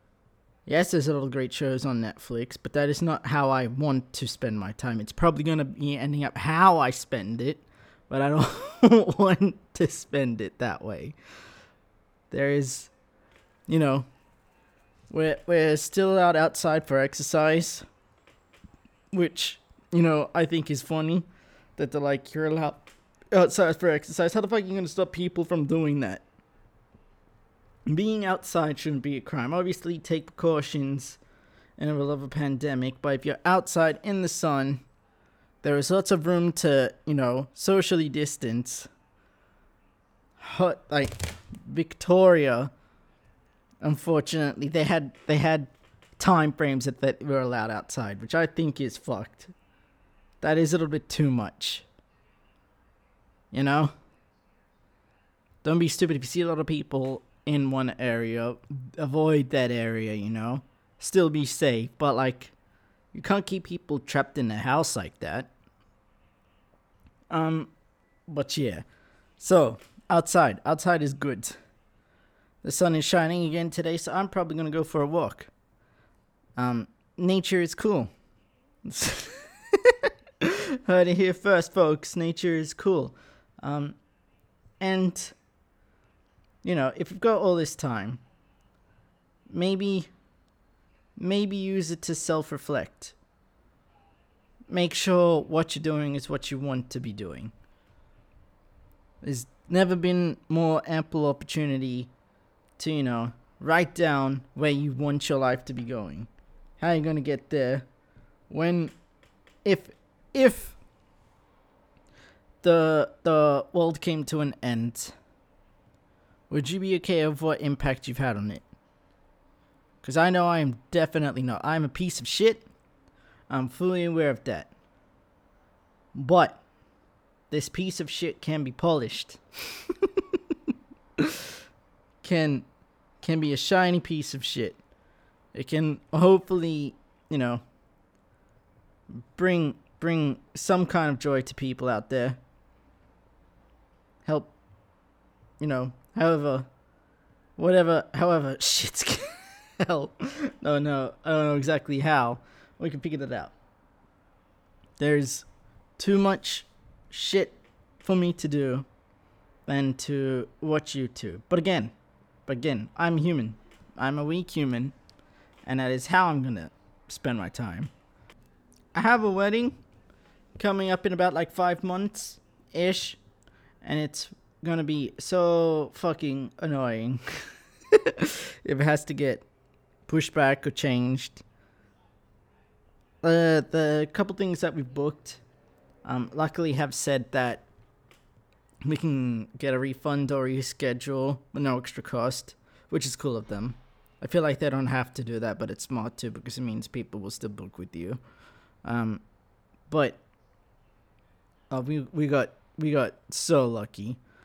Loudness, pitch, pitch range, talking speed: -27 LUFS, 145 Hz, 125-165 Hz, 135 wpm